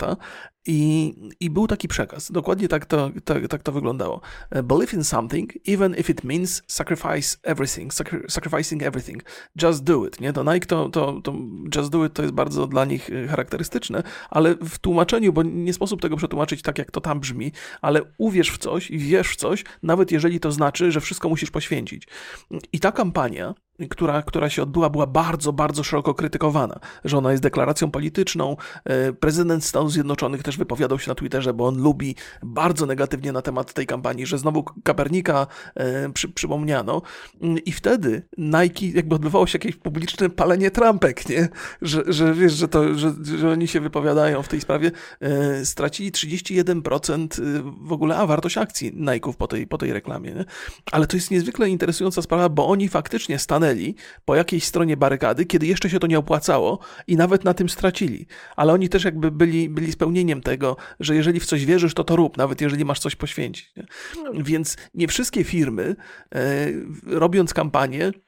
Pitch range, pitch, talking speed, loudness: 150-175 Hz, 160 Hz, 175 wpm, -22 LUFS